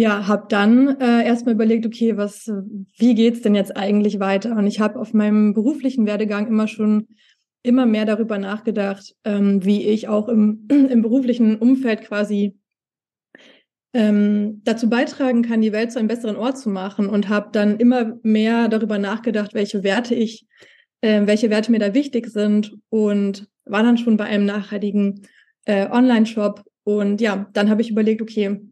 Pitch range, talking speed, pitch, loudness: 205-230 Hz, 175 wpm, 215 Hz, -19 LUFS